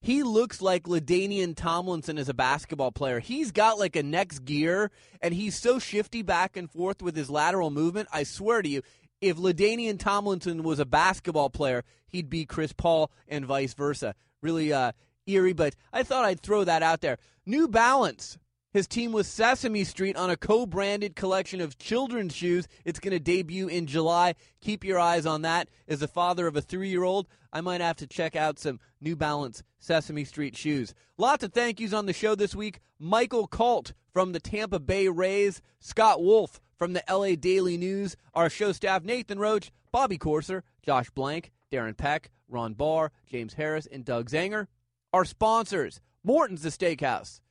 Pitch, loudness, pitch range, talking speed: 175 Hz, -28 LUFS, 155-200 Hz, 185 wpm